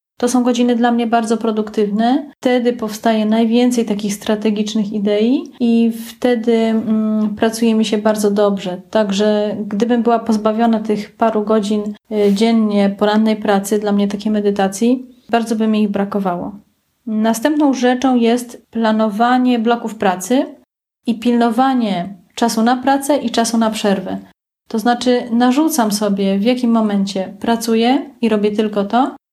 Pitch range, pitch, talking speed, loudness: 210-240 Hz, 225 Hz, 135 wpm, -16 LUFS